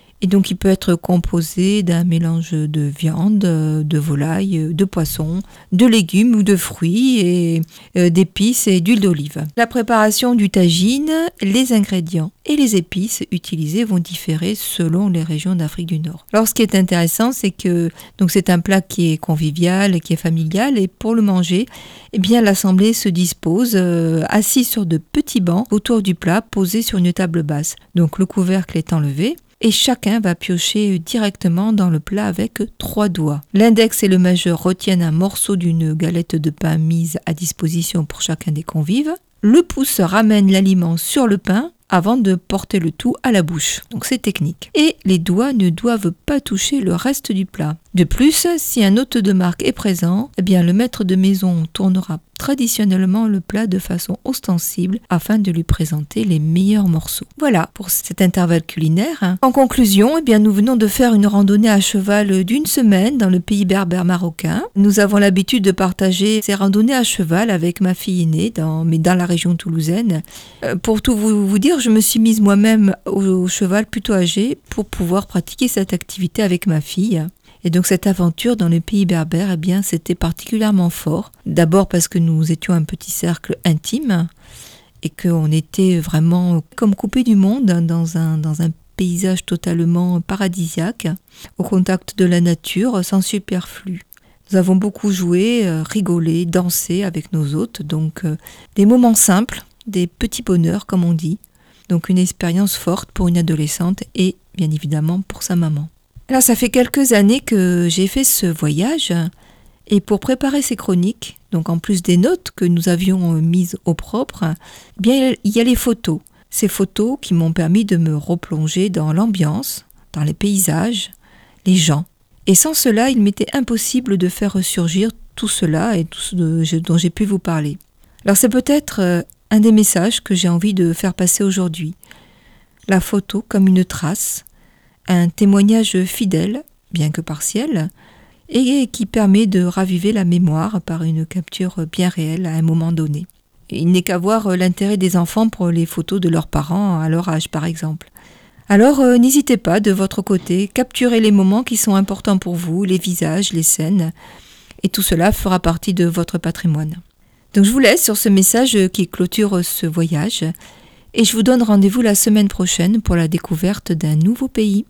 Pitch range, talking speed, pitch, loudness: 170-215 Hz, 180 wpm, 185 Hz, -16 LUFS